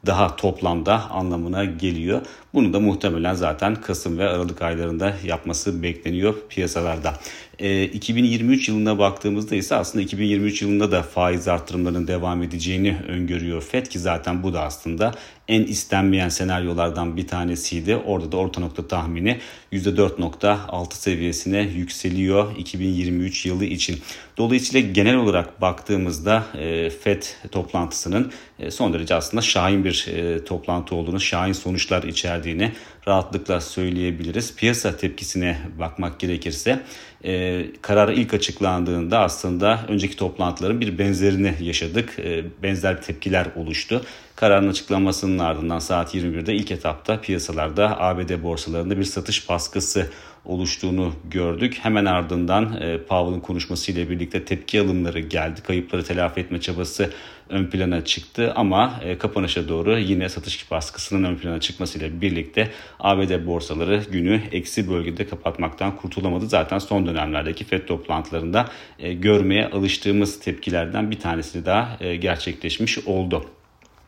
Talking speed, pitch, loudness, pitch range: 115 wpm, 90 Hz, -22 LUFS, 85-100 Hz